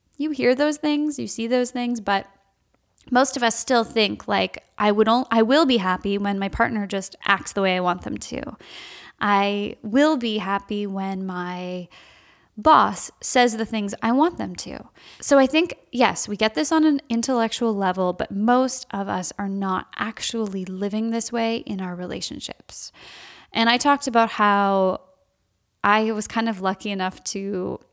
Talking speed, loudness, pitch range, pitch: 180 wpm, -22 LUFS, 195-245 Hz, 220 Hz